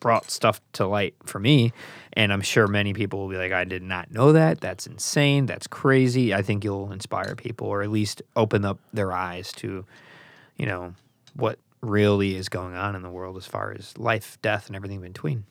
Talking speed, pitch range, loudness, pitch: 215 wpm, 95-115 Hz, -24 LUFS, 105 Hz